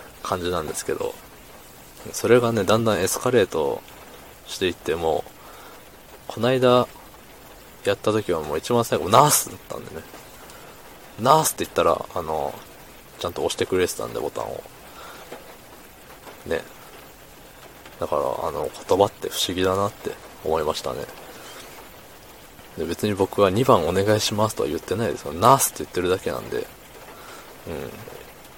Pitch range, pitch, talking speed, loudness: 100-130 Hz, 110 Hz, 295 characters per minute, -22 LUFS